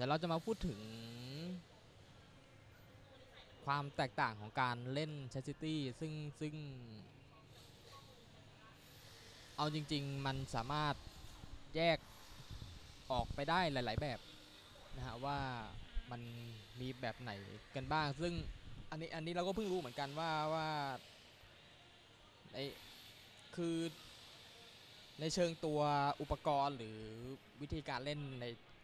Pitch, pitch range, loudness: 135 Hz, 115-150 Hz, -42 LUFS